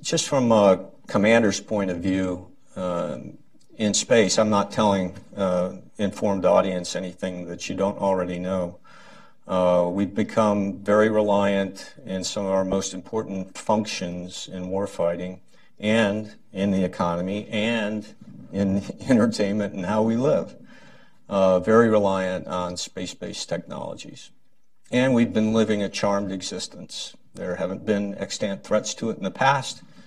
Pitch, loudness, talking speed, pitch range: 100 Hz, -24 LUFS, 140 wpm, 95-105 Hz